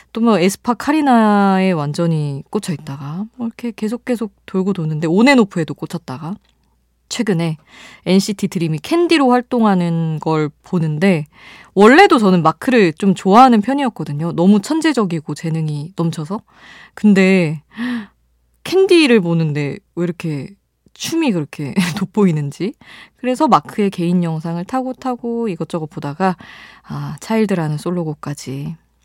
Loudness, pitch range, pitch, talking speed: -16 LUFS, 160-225 Hz, 185 Hz, 305 characters per minute